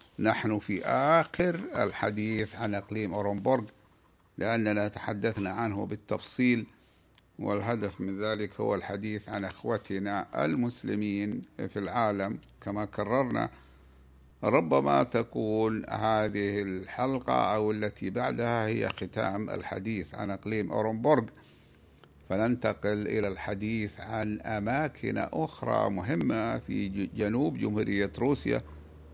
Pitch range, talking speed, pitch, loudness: 100-110 Hz, 95 wpm, 105 Hz, -30 LUFS